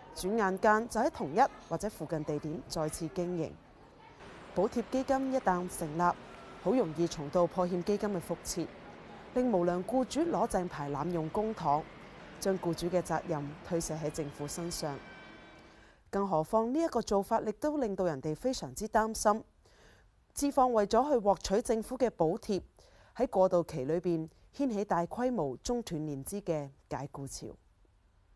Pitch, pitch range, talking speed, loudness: 180 Hz, 160-220 Hz, 240 characters per minute, -33 LUFS